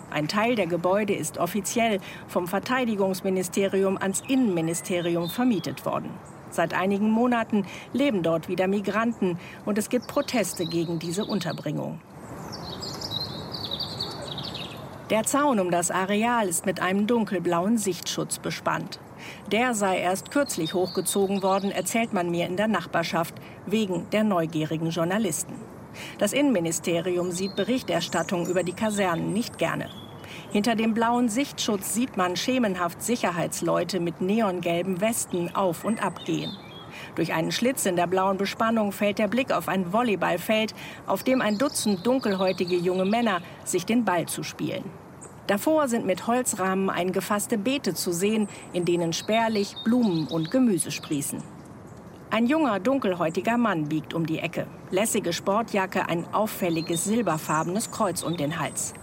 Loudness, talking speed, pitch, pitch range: -26 LUFS, 135 wpm, 195 Hz, 175-225 Hz